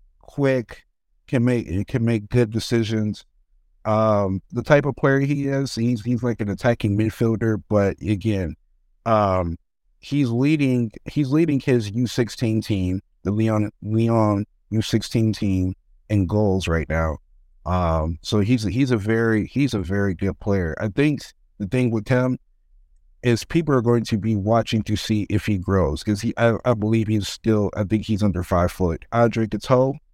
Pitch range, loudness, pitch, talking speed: 95-120 Hz, -22 LUFS, 110 Hz, 170 wpm